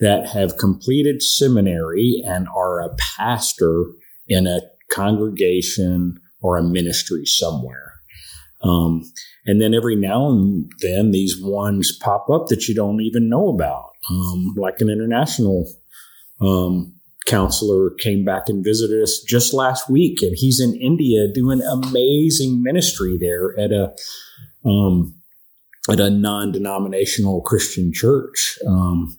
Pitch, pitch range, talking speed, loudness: 100 Hz, 90-110 Hz, 130 wpm, -18 LUFS